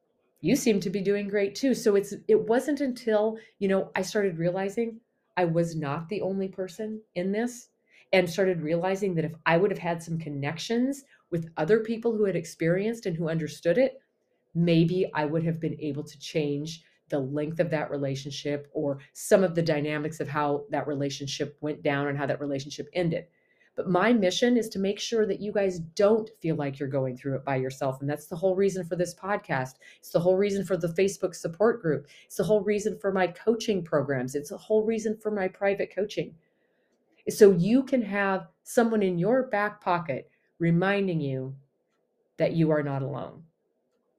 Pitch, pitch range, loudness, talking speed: 185 Hz, 150-210 Hz, -27 LUFS, 195 wpm